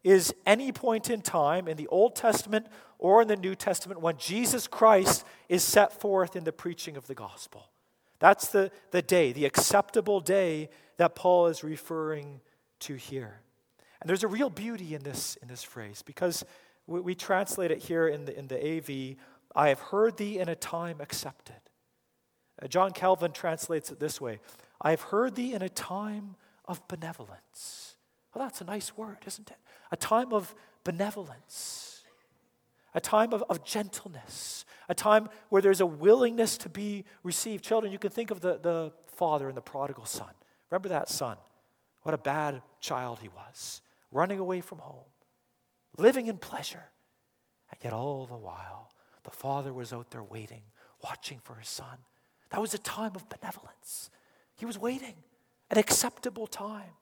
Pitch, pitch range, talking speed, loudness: 180 Hz, 150-210 Hz, 175 wpm, -29 LUFS